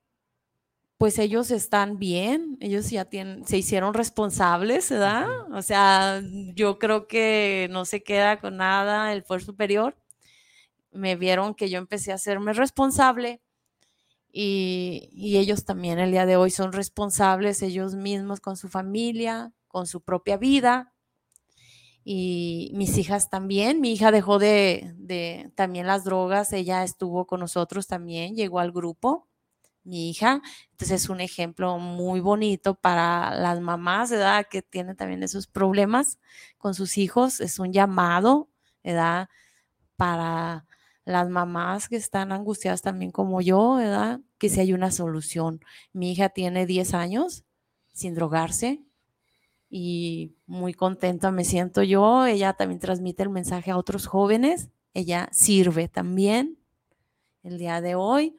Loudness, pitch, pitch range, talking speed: -24 LUFS, 195 Hz, 180-210 Hz, 140 wpm